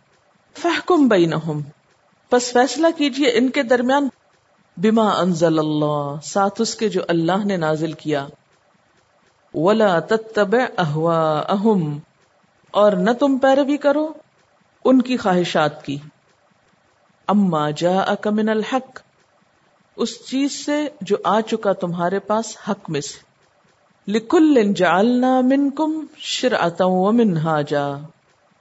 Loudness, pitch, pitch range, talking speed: -19 LUFS, 205 Hz, 165-255 Hz, 105 wpm